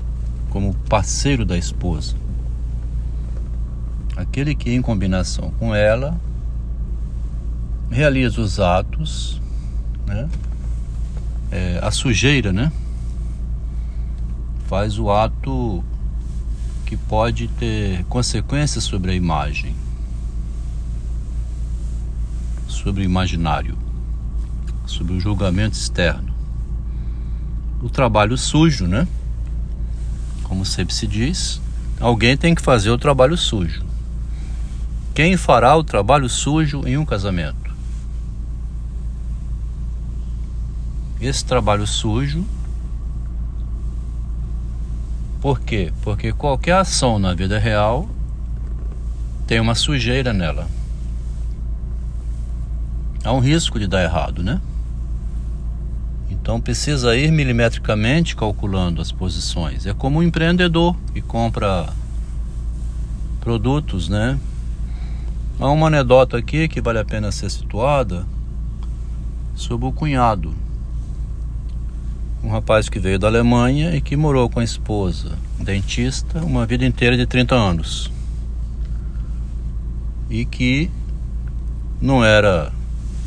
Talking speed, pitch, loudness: 95 wpm, 65 Hz, -20 LUFS